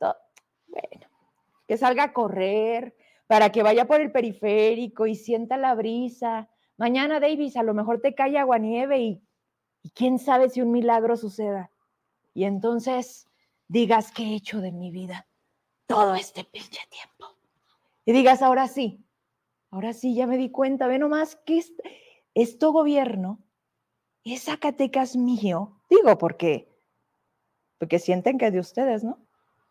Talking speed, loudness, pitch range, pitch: 150 wpm, -23 LUFS, 215-260 Hz, 235 Hz